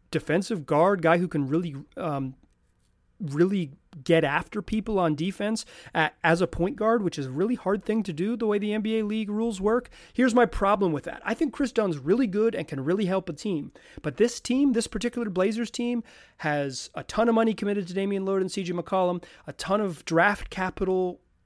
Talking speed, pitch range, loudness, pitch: 205 wpm, 170-220 Hz, -26 LUFS, 195 Hz